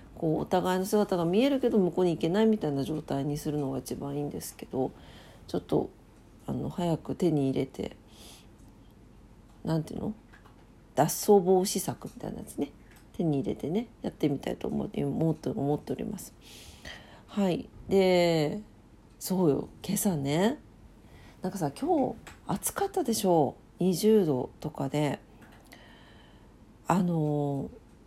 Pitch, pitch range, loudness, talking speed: 160 Hz, 135-195 Hz, -29 LUFS, 270 characters per minute